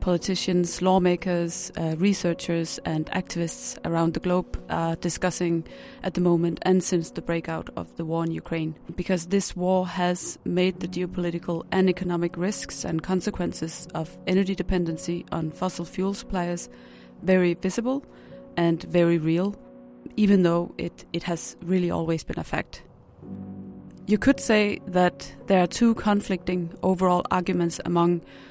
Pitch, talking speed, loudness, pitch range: 175 Hz, 145 wpm, -25 LUFS, 165-185 Hz